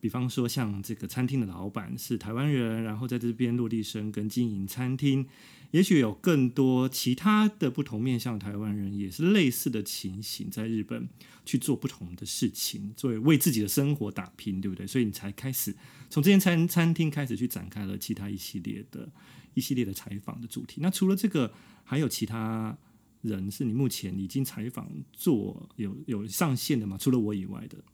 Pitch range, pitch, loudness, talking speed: 105-135 Hz, 120 Hz, -29 LUFS, 295 characters per minute